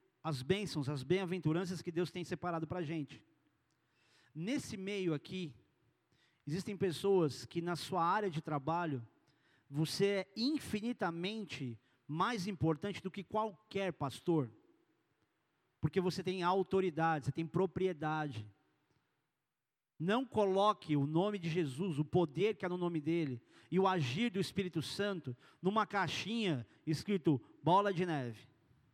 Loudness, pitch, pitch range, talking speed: -37 LUFS, 175 Hz, 150-195 Hz, 130 wpm